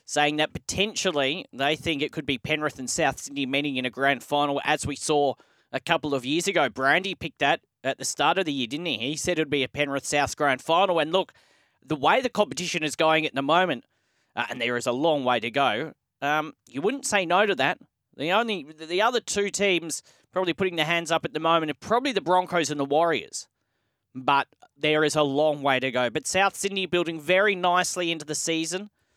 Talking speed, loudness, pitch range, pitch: 230 wpm, -25 LUFS, 140-175 Hz, 155 Hz